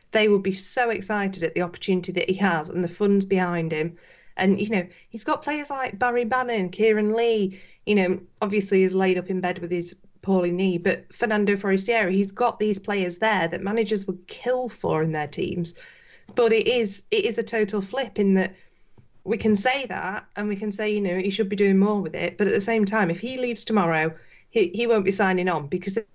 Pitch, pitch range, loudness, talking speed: 200 Hz, 185-220 Hz, -24 LUFS, 225 wpm